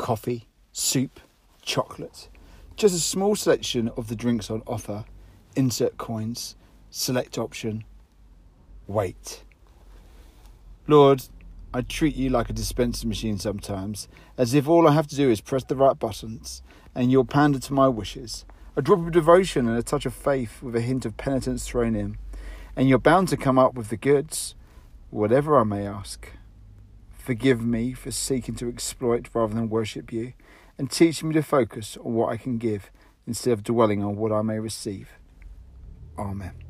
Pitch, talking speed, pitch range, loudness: 115 Hz, 165 wpm, 100-130 Hz, -24 LUFS